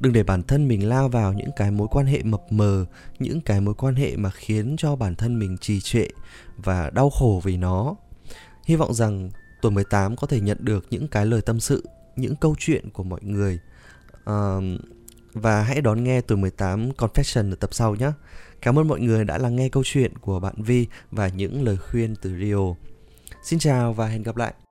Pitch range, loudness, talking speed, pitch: 100-130 Hz, -23 LUFS, 215 wpm, 110 Hz